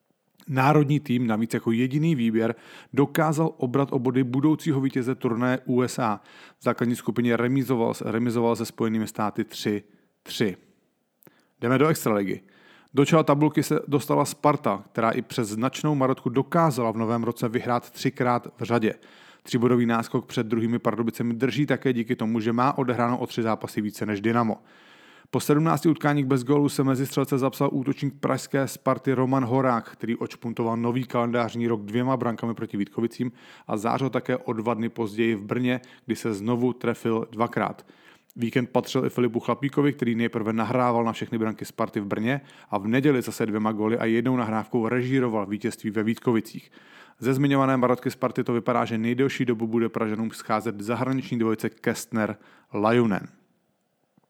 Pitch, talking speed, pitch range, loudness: 120 Hz, 155 wpm, 115-135 Hz, -25 LUFS